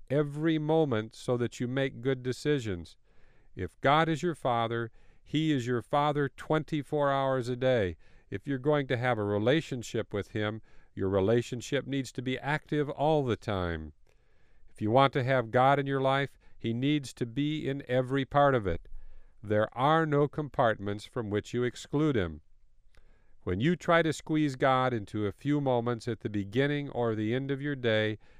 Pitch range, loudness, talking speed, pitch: 110-145 Hz, -30 LUFS, 180 wpm, 130 Hz